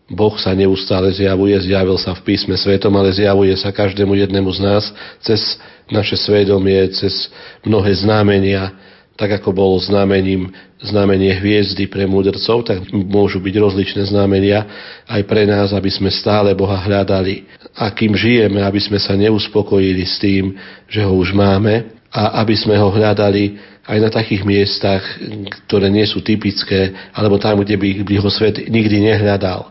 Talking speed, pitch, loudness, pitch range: 155 wpm, 100 Hz, -14 LUFS, 95-105 Hz